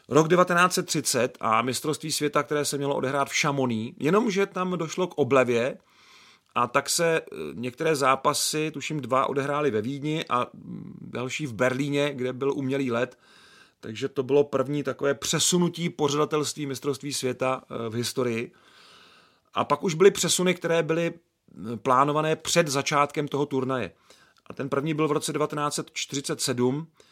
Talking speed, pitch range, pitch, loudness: 140 wpm, 130-160 Hz, 145 Hz, -25 LUFS